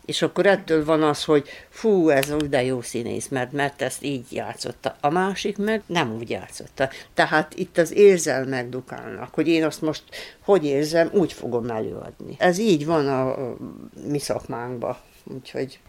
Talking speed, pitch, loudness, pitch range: 160 wpm, 150 Hz, -23 LUFS, 130-165 Hz